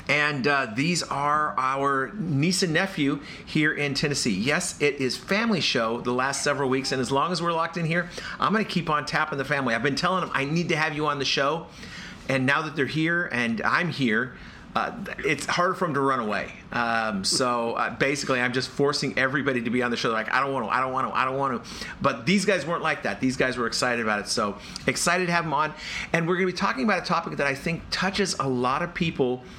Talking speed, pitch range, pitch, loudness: 255 wpm, 130-170 Hz, 140 Hz, -25 LUFS